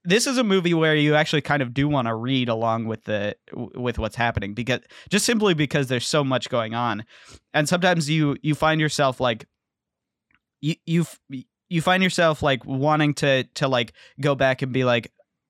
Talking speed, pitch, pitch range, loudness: 195 wpm, 140 Hz, 120-155 Hz, -22 LUFS